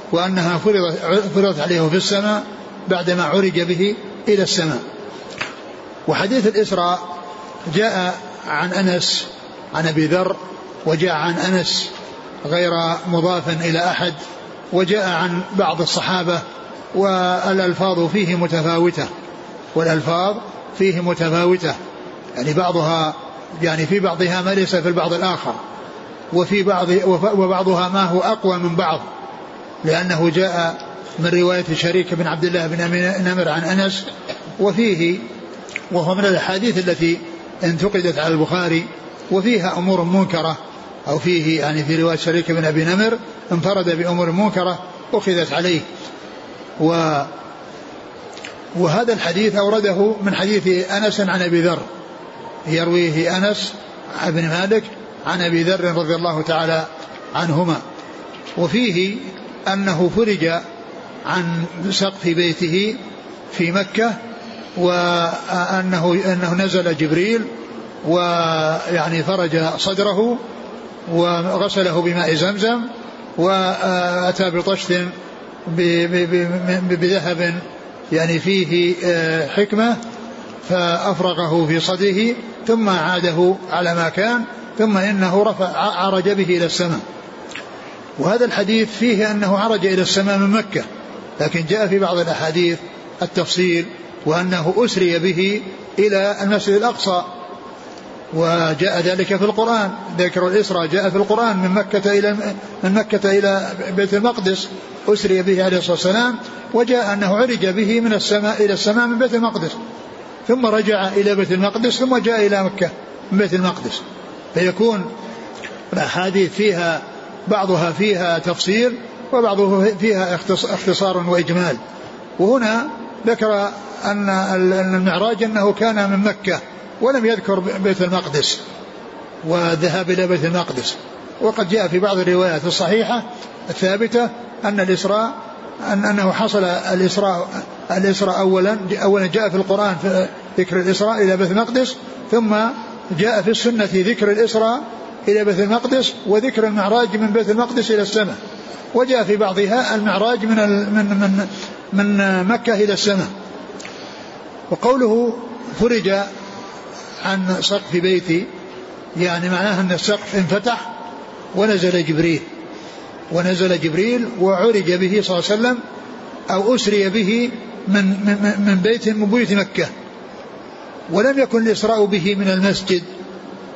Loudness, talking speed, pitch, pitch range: -18 LUFS, 115 wpm, 190 Hz, 175-210 Hz